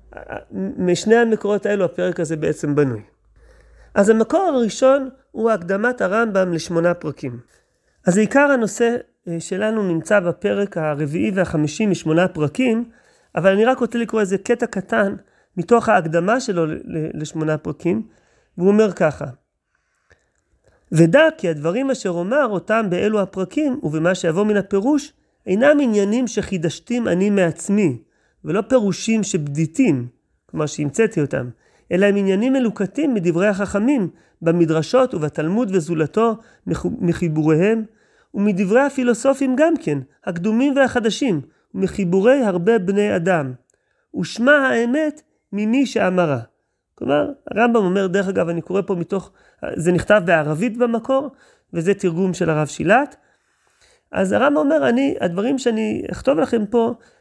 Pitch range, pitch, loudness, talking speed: 170-235 Hz, 200 Hz, -19 LUFS, 125 wpm